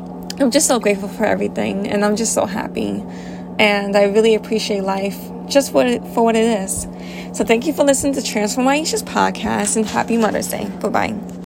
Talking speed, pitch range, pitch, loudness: 200 wpm, 205-240 Hz, 215 Hz, -17 LUFS